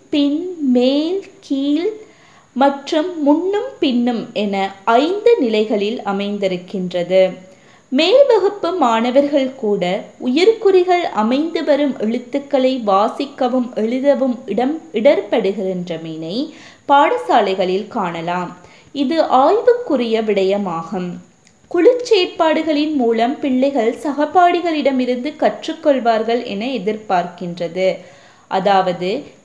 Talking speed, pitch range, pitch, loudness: 70 wpm, 200-310 Hz, 255 Hz, -17 LUFS